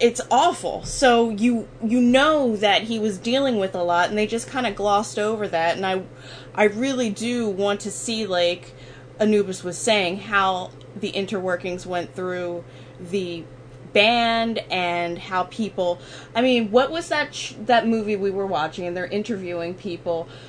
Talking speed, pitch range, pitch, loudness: 170 wpm, 175-230 Hz, 200 Hz, -22 LUFS